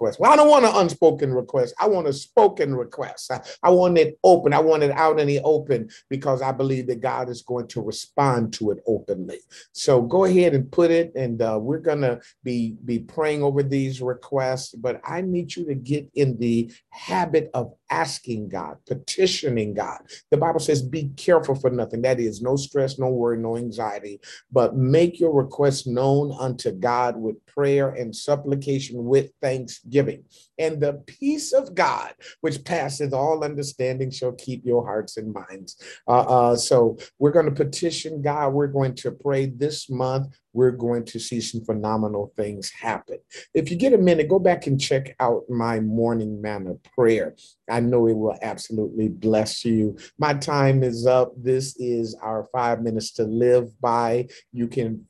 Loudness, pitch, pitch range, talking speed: -22 LUFS, 130 Hz, 115-150 Hz, 185 wpm